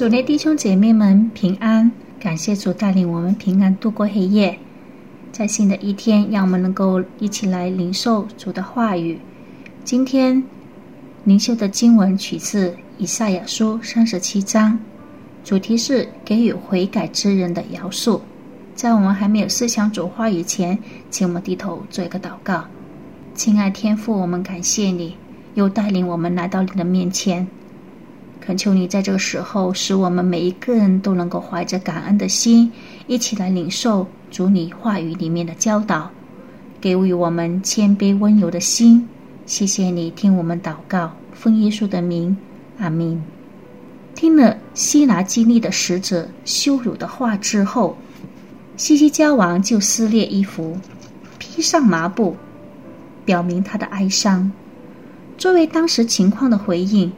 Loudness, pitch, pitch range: -18 LUFS, 200 Hz, 185-230 Hz